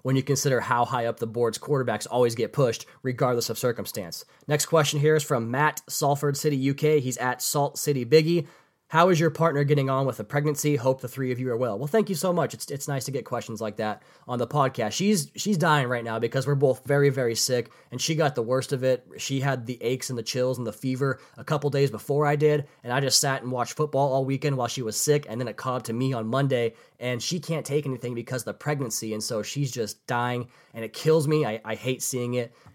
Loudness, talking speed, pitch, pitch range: -26 LUFS, 255 wpm, 135 Hz, 120-150 Hz